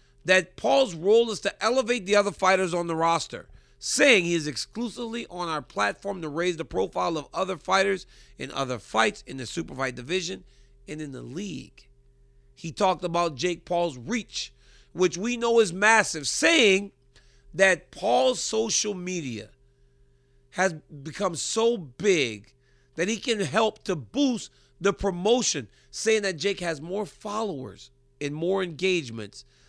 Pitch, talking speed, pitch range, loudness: 175 Hz, 150 wpm, 130-200 Hz, -25 LUFS